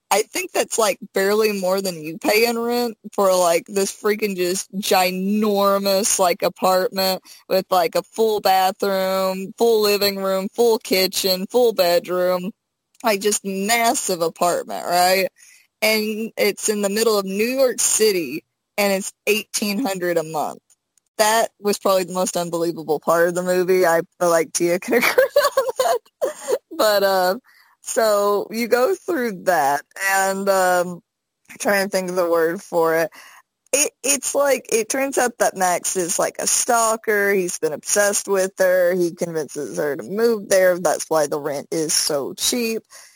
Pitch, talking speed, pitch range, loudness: 195 Hz, 165 wpm, 185-225 Hz, -19 LUFS